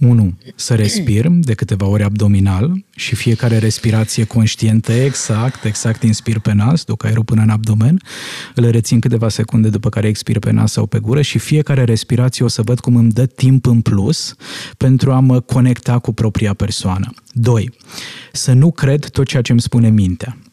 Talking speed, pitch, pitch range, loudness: 180 wpm, 115 Hz, 110-125 Hz, -14 LUFS